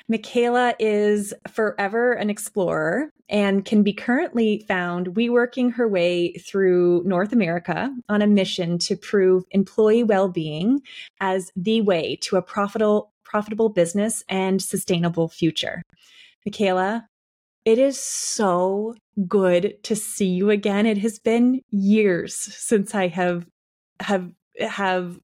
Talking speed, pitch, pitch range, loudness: 125 wpm, 205 Hz, 185-225 Hz, -22 LUFS